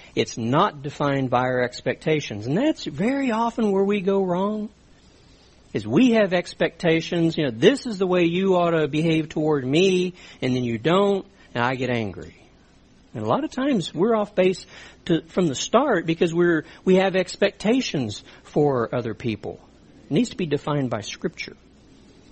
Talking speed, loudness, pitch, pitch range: 175 wpm, -22 LUFS, 170 Hz, 135-195 Hz